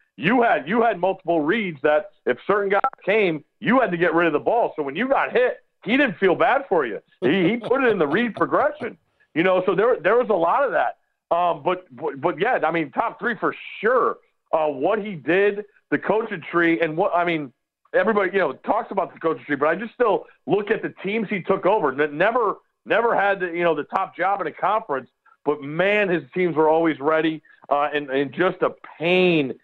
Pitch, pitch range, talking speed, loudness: 175 Hz, 155-205 Hz, 230 wpm, -21 LUFS